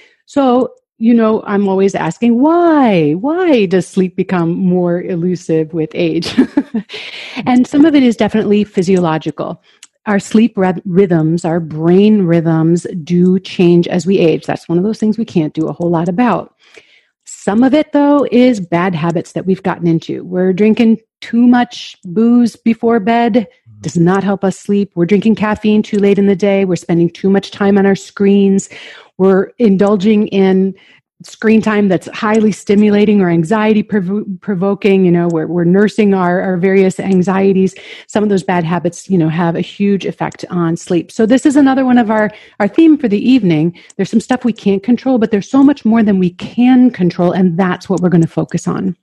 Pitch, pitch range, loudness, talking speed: 195 Hz, 175-225 Hz, -12 LUFS, 190 wpm